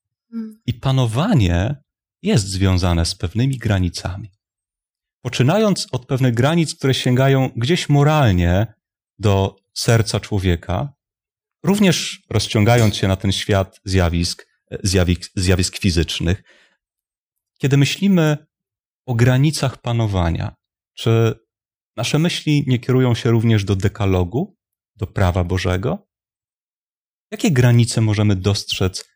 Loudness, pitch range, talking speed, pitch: -18 LUFS, 95-135 Hz, 100 wpm, 110 Hz